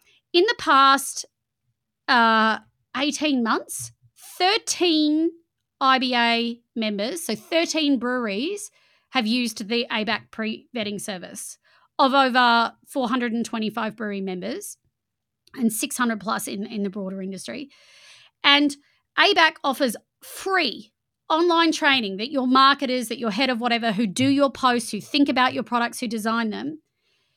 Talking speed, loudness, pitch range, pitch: 125 wpm, -22 LUFS, 225-285 Hz, 245 Hz